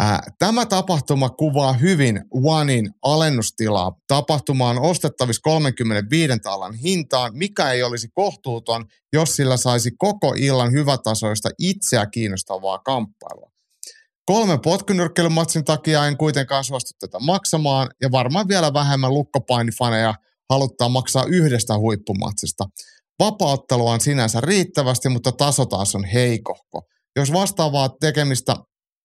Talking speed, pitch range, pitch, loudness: 110 wpm, 115-155 Hz, 135 Hz, -19 LUFS